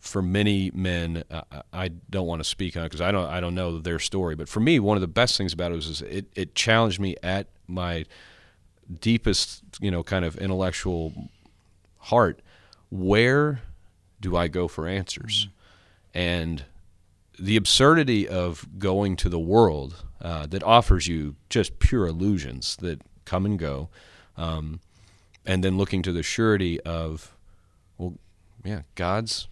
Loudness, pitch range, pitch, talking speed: -25 LUFS, 85-100 Hz, 90 Hz, 165 wpm